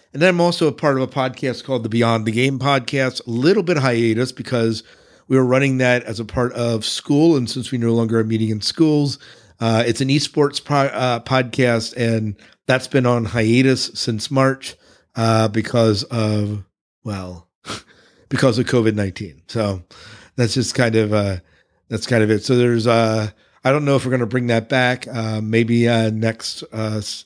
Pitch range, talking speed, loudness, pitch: 110-130 Hz, 190 wpm, -18 LUFS, 120 Hz